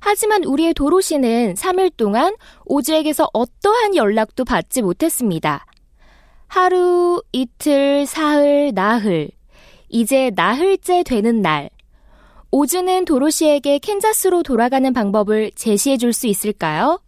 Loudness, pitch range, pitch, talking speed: -17 LUFS, 225-355 Hz, 285 Hz, 265 characters per minute